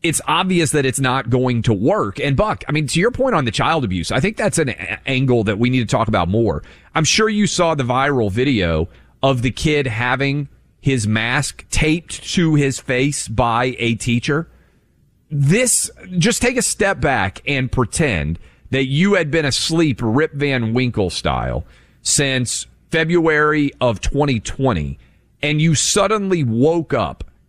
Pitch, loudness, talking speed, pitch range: 135 Hz, -17 LUFS, 170 wpm, 115-160 Hz